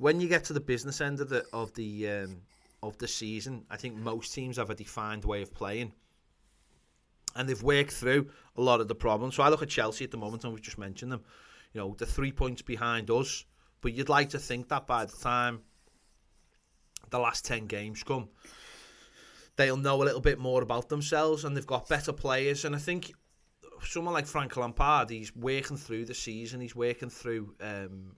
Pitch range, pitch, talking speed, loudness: 110-140 Hz, 125 Hz, 205 wpm, -32 LUFS